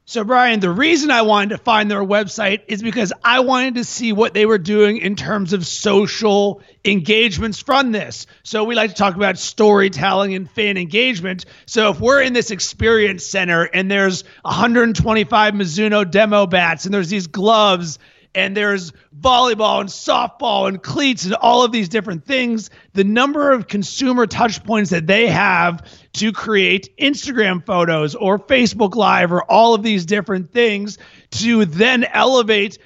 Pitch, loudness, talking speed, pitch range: 210 Hz, -16 LUFS, 170 wpm, 195-230 Hz